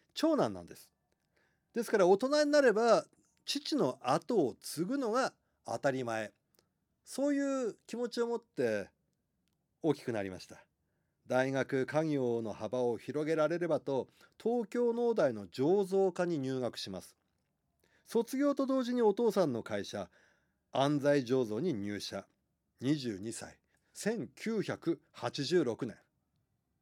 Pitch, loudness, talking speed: 155 Hz, -33 LUFS, 215 characters per minute